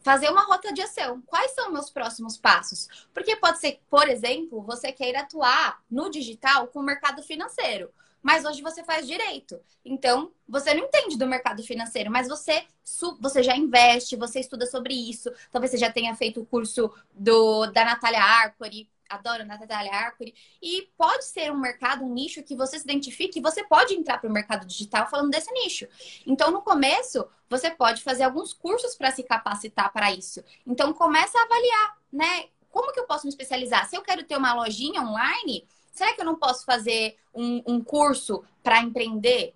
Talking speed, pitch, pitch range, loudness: 190 wpm, 265 Hz, 235-315 Hz, -24 LUFS